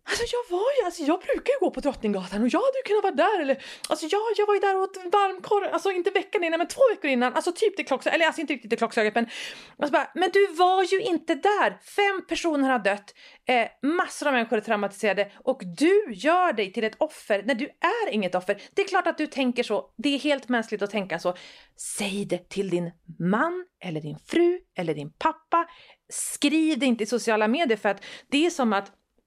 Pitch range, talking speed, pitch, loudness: 220-360 Hz, 235 wpm, 295 Hz, -25 LUFS